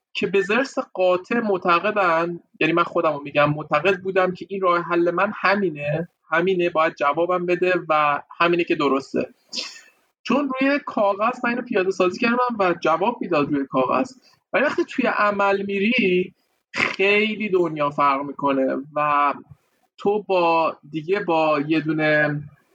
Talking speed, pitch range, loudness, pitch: 145 wpm, 155-200 Hz, -21 LUFS, 180 Hz